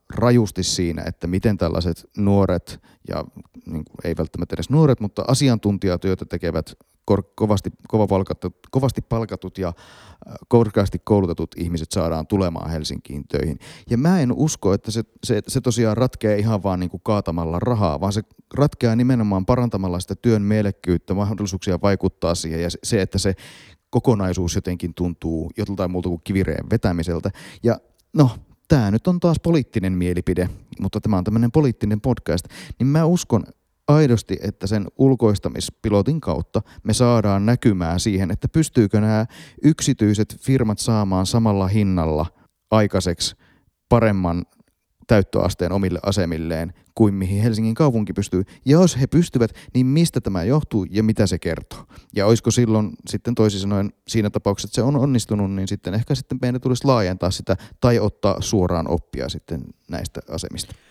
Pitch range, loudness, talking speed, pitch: 90-120 Hz, -21 LUFS, 150 wpm, 100 Hz